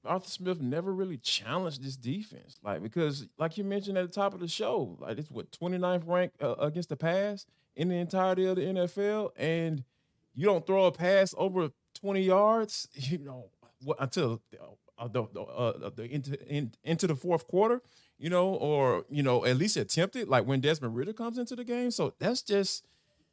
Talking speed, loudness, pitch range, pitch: 195 wpm, -31 LUFS, 140-195 Hz, 175 Hz